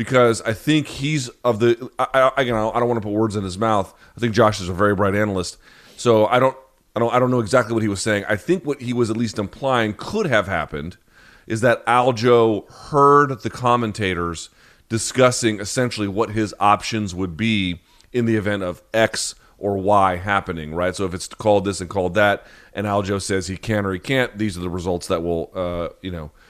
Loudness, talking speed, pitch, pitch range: -20 LUFS, 220 wpm, 110 Hz, 95-120 Hz